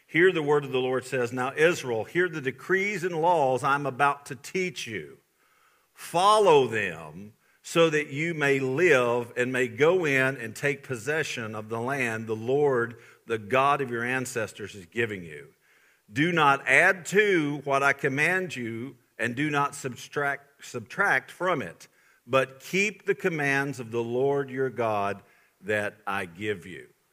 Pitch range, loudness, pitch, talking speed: 120-150 Hz, -26 LUFS, 135 Hz, 165 wpm